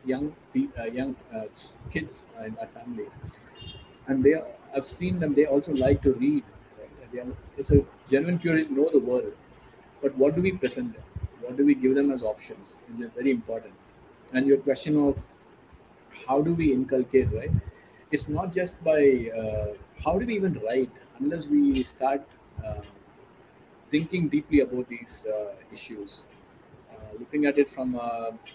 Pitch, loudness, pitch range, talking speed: 140 Hz, -26 LUFS, 125-155 Hz, 170 wpm